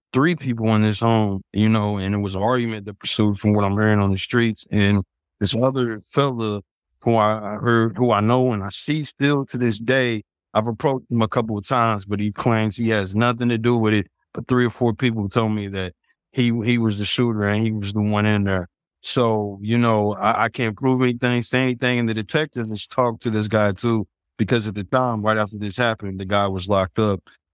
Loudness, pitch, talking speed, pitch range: -21 LUFS, 110 Hz, 235 wpm, 105-120 Hz